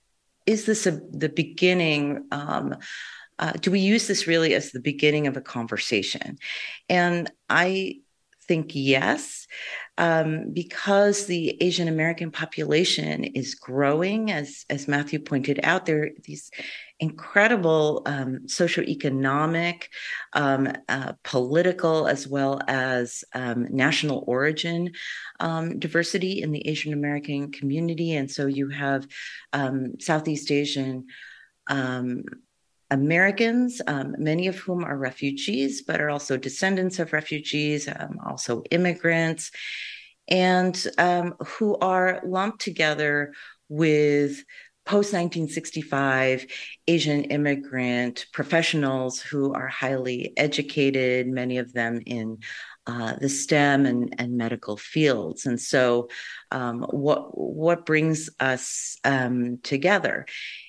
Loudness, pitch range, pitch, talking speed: -24 LUFS, 135-170 Hz, 150 Hz, 115 wpm